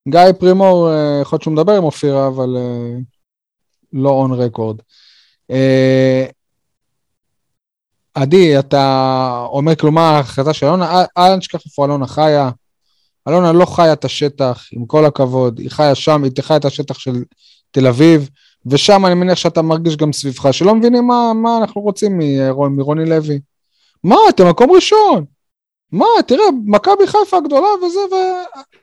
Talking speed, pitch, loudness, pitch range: 140 wpm, 155 Hz, -12 LUFS, 135-185 Hz